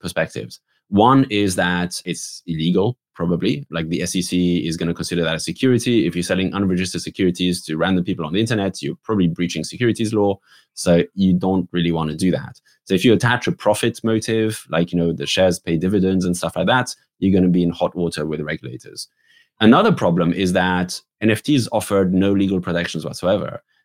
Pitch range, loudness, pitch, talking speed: 85-100 Hz, -19 LUFS, 90 Hz, 200 wpm